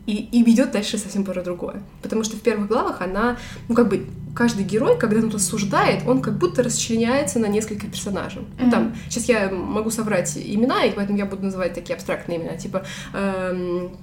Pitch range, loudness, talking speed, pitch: 185-230 Hz, -22 LUFS, 195 wpm, 210 Hz